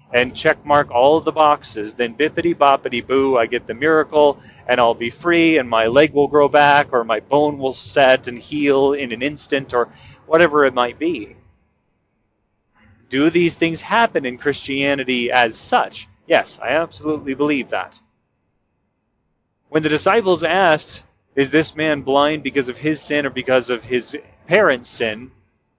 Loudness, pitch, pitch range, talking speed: -17 LUFS, 140 Hz, 125-150 Hz, 165 wpm